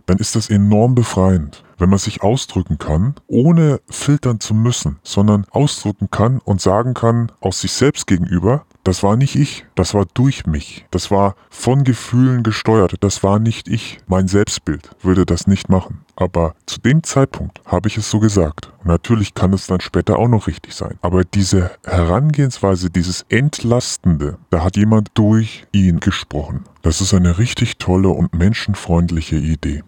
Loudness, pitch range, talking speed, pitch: -16 LUFS, 90-115 Hz, 170 wpm, 100 Hz